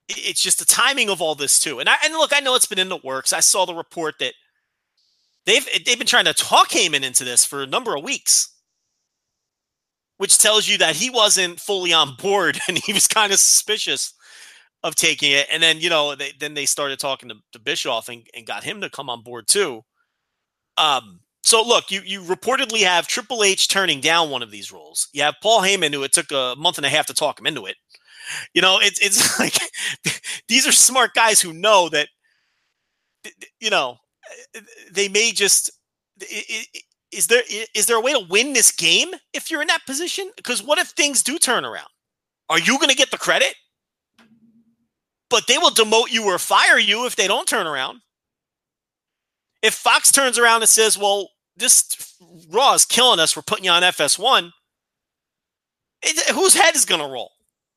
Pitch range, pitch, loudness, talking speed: 165-250 Hz, 205 Hz, -16 LUFS, 200 wpm